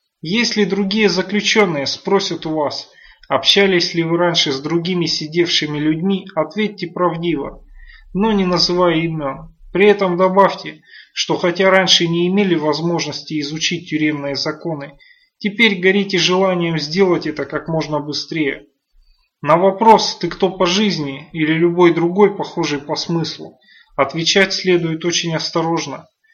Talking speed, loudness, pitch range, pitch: 130 wpm, -16 LUFS, 160-195 Hz, 175 Hz